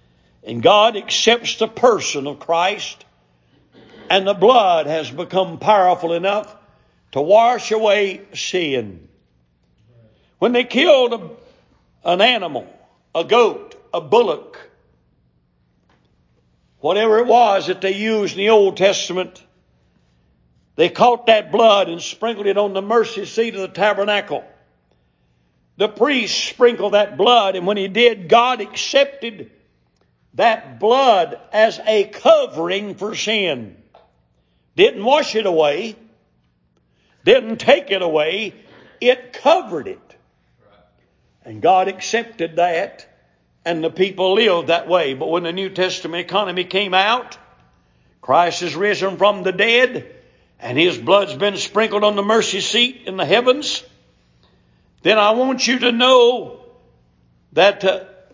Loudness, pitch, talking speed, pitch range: -16 LUFS, 195 Hz, 130 wpm, 160-225 Hz